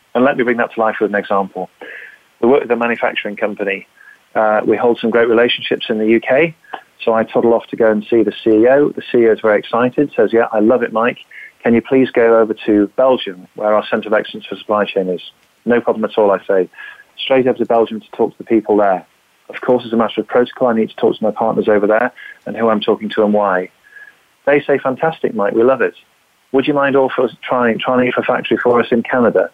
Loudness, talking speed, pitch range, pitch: -15 LUFS, 245 wpm, 110-125 Hz, 115 Hz